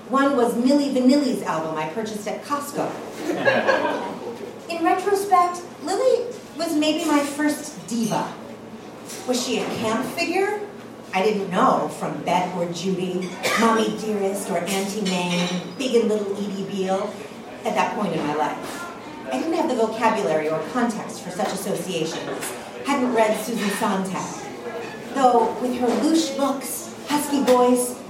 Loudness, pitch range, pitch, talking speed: -23 LUFS, 200-275 Hz, 230 Hz, 140 wpm